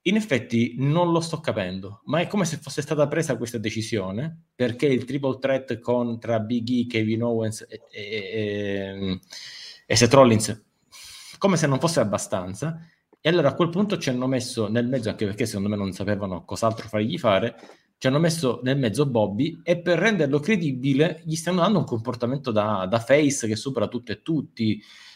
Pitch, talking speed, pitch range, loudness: 125 Hz, 185 wpm, 110-155 Hz, -24 LUFS